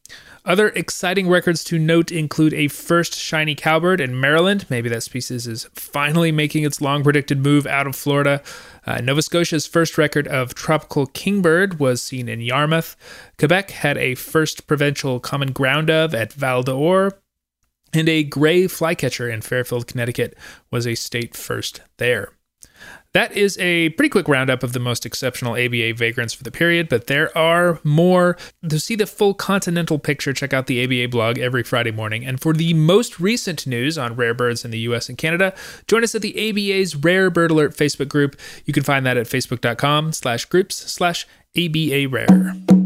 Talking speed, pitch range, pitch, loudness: 175 wpm, 125-170 Hz, 150 Hz, -19 LUFS